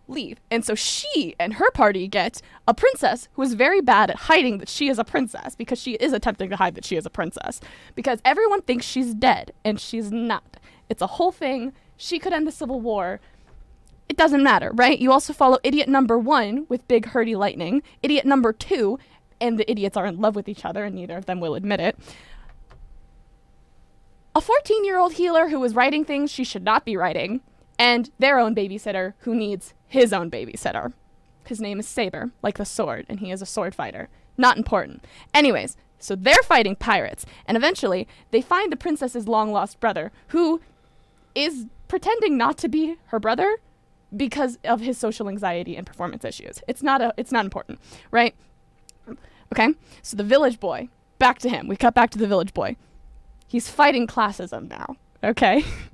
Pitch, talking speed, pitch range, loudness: 240 Hz, 190 wpm, 205-275 Hz, -22 LUFS